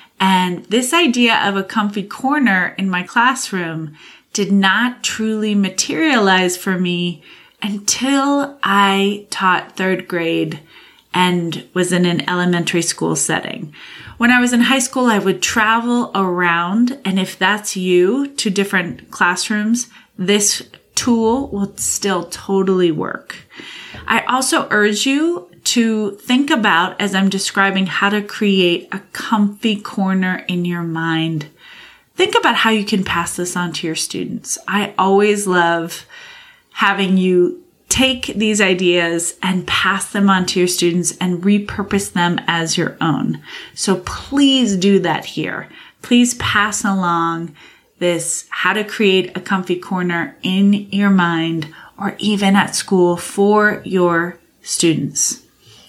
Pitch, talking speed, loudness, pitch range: 195 Hz, 135 wpm, -16 LUFS, 180-220 Hz